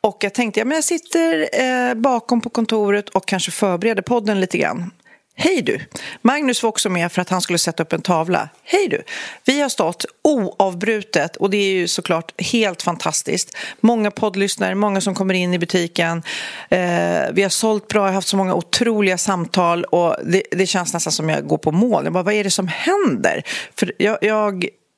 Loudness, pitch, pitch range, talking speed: -18 LUFS, 200 Hz, 180-230 Hz, 195 wpm